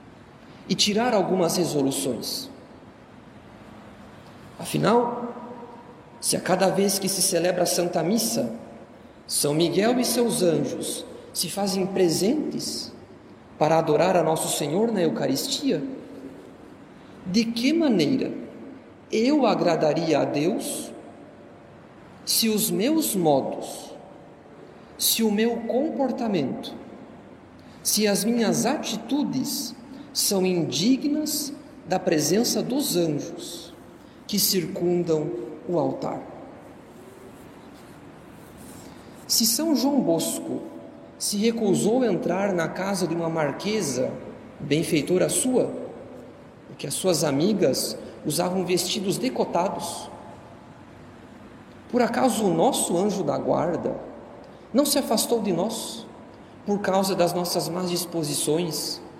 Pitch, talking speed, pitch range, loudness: 200 Hz, 100 wpm, 175-245 Hz, -24 LUFS